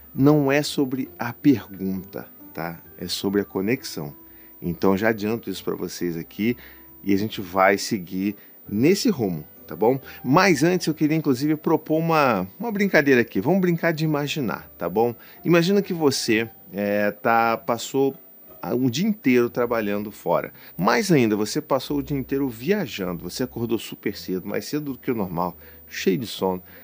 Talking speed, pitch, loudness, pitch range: 165 wpm, 120 Hz, -23 LUFS, 95-150 Hz